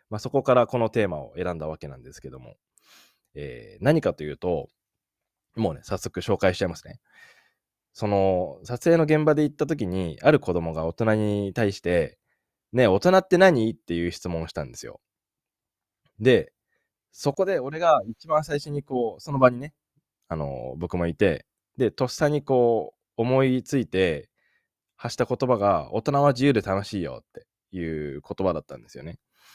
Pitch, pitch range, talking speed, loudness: 115 Hz, 90-140 Hz, 315 characters per minute, -24 LUFS